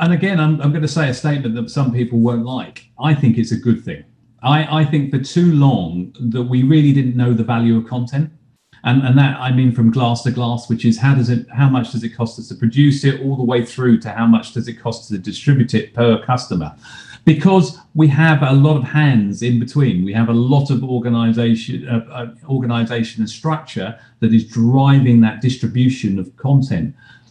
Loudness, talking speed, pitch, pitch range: -16 LUFS, 220 wpm, 125 Hz, 115-140 Hz